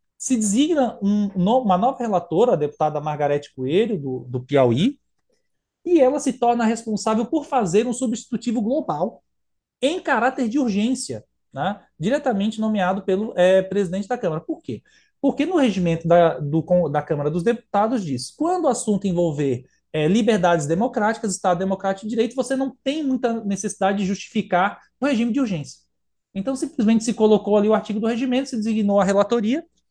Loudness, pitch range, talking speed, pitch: -21 LUFS, 180-255 Hz, 165 wpm, 215 Hz